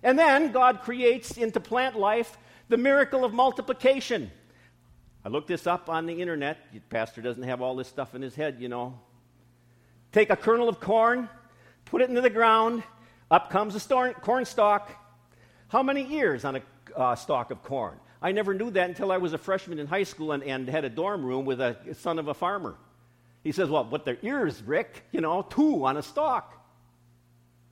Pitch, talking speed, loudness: 170 Hz, 200 wpm, -27 LUFS